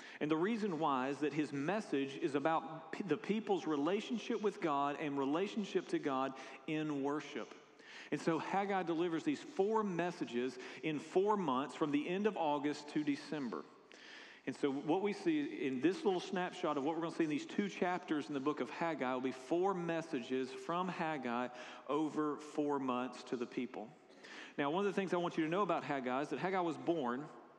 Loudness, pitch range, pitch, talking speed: -38 LUFS, 140-195 Hz, 160 Hz, 200 wpm